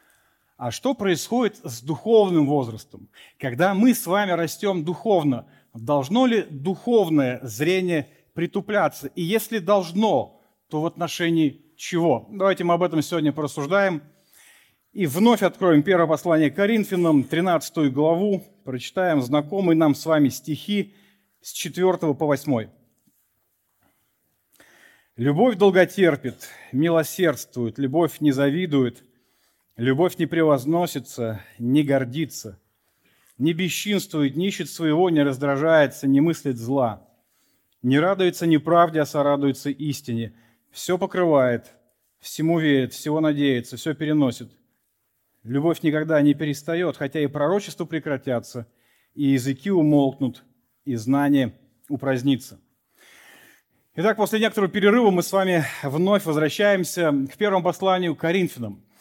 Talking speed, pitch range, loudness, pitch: 110 wpm, 140-180 Hz, -22 LUFS, 155 Hz